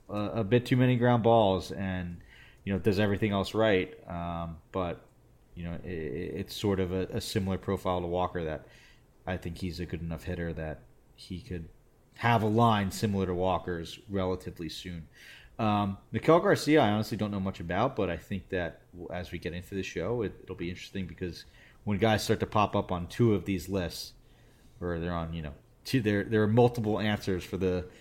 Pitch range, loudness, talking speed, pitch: 90-110 Hz, -30 LUFS, 200 wpm, 95 Hz